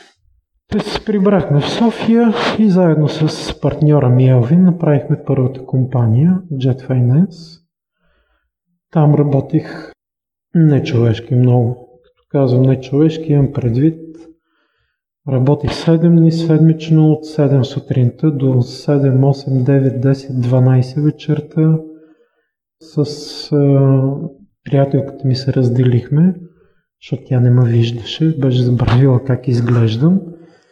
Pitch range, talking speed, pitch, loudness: 130-160 Hz, 110 wpm, 140 Hz, -14 LUFS